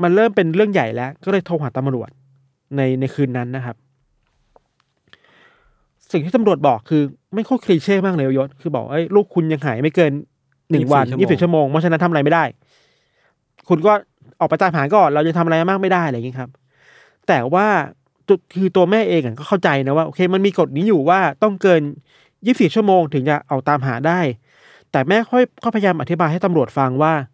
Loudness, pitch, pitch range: -17 LUFS, 160 Hz, 135-190 Hz